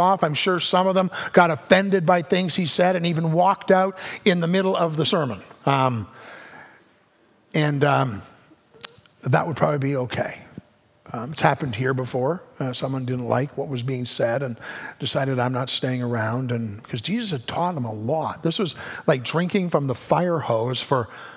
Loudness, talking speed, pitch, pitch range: -22 LUFS, 195 wpm, 150 Hz, 125-180 Hz